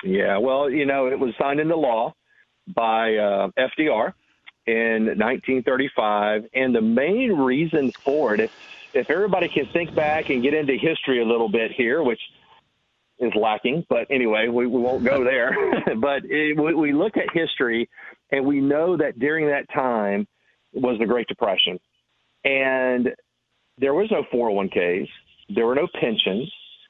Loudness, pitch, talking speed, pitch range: -22 LUFS, 130 Hz, 160 wpm, 115-150 Hz